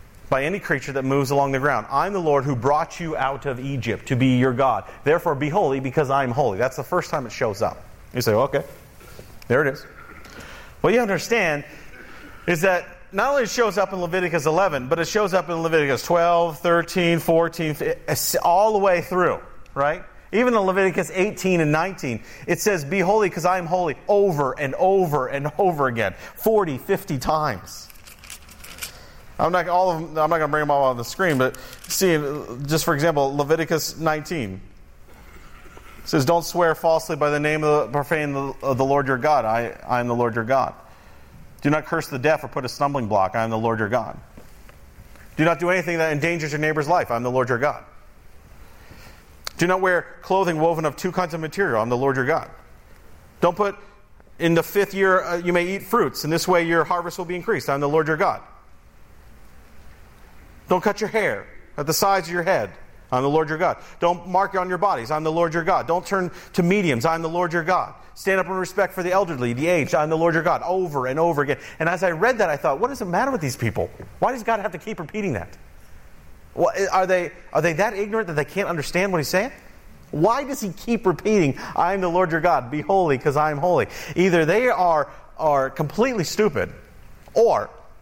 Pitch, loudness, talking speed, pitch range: 160 Hz, -22 LUFS, 210 wpm, 135-185 Hz